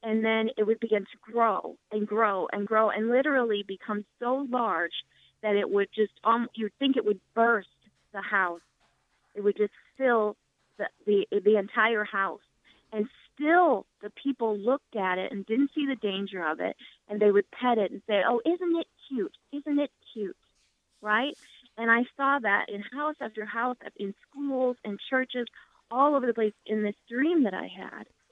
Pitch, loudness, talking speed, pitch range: 220 Hz, -28 LUFS, 185 wpm, 205-250 Hz